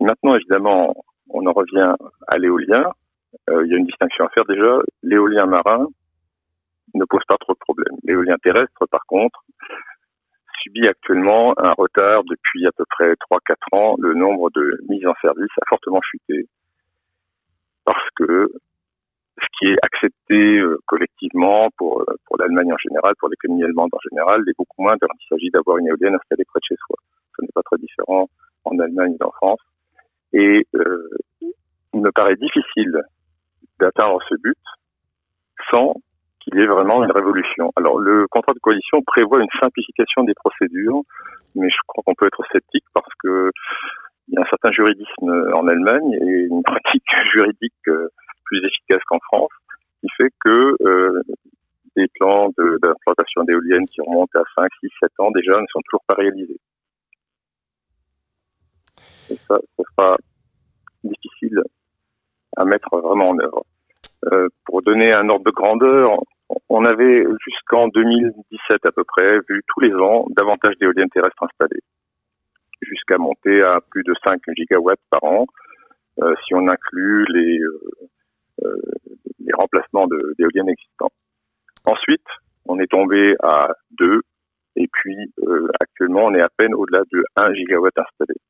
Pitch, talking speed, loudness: 105 Hz, 155 wpm, -17 LUFS